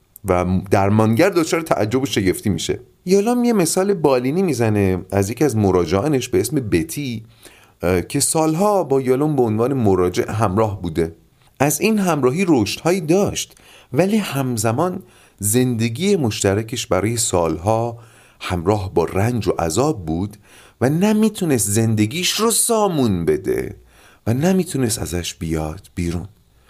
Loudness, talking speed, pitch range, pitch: -18 LUFS, 125 wpm, 100-160 Hz, 115 Hz